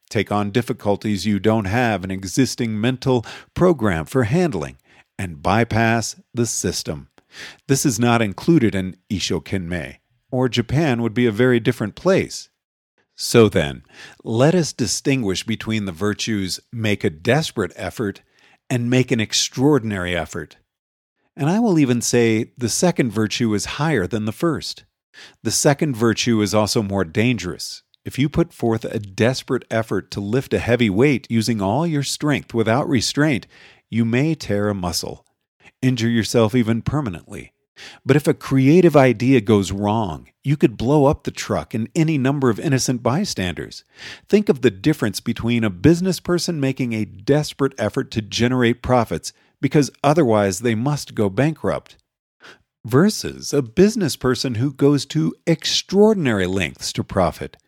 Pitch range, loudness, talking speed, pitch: 105-140 Hz, -19 LUFS, 150 wpm, 120 Hz